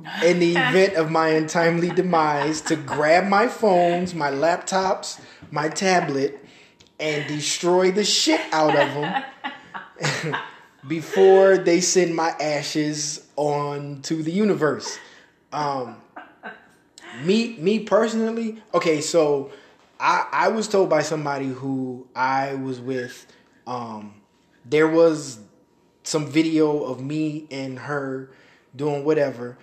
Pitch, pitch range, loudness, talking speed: 155 Hz, 145-180 Hz, -21 LUFS, 115 wpm